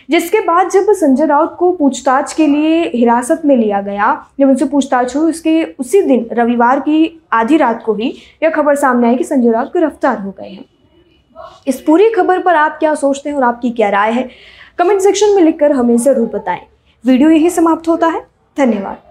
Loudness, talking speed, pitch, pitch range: -12 LUFS, 200 wpm, 290 Hz, 245-325 Hz